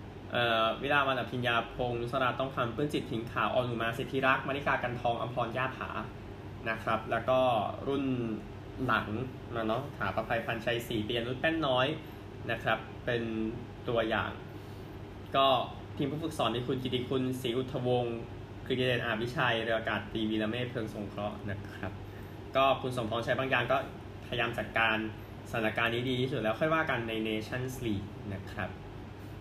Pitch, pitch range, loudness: 115 Hz, 105-125 Hz, -32 LUFS